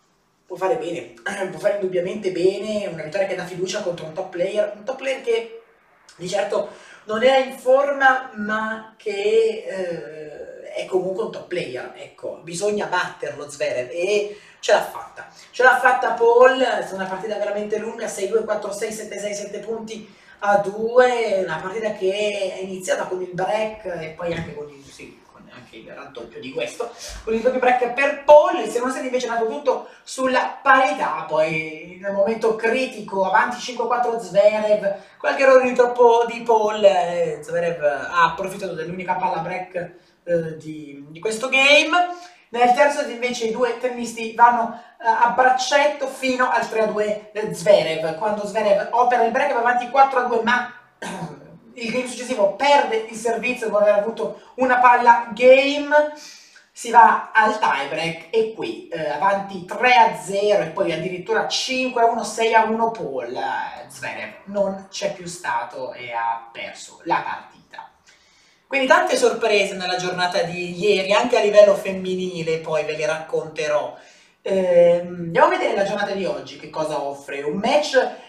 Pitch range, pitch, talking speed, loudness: 185-245 Hz, 210 Hz, 160 wpm, -20 LUFS